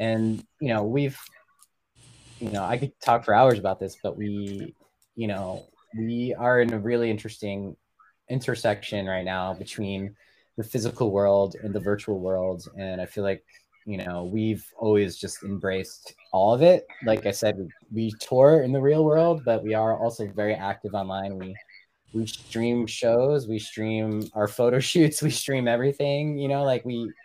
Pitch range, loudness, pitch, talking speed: 100-120 Hz, -25 LUFS, 110 Hz, 175 wpm